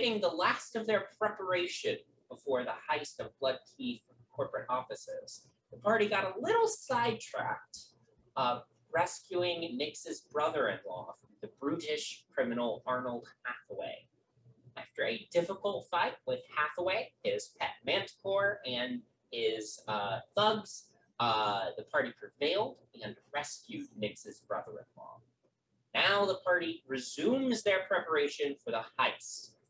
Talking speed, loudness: 125 wpm, -34 LUFS